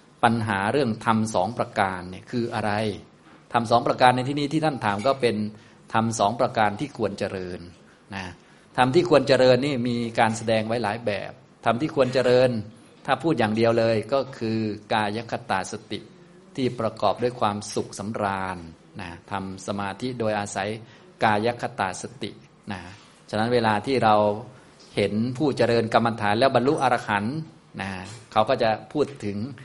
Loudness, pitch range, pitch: -24 LUFS, 105-125 Hz, 115 Hz